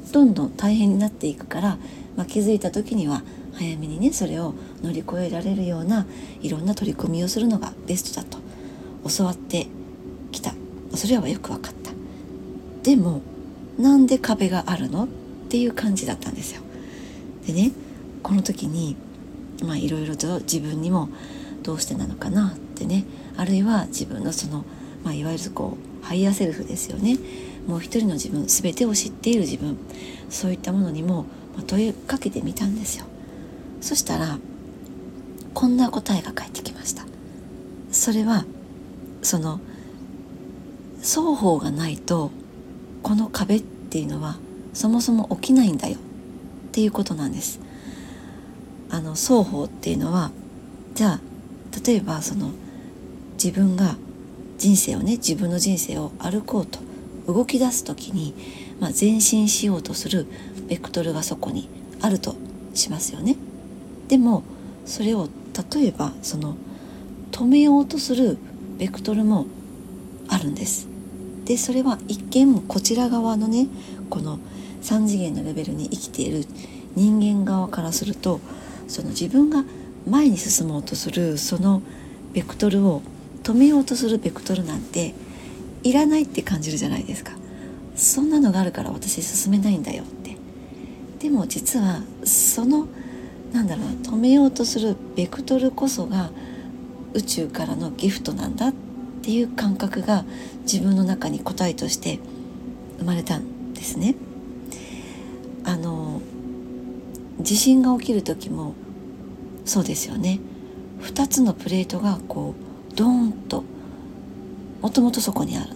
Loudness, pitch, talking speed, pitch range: -22 LUFS, 210 Hz, 285 characters per minute, 175-245 Hz